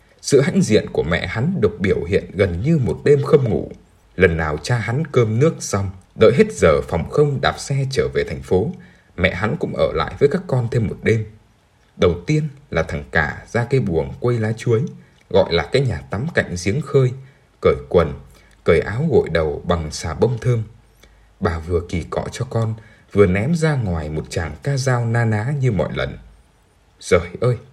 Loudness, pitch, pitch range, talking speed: -19 LUFS, 115 Hz, 100-140 Hz, 205 wpm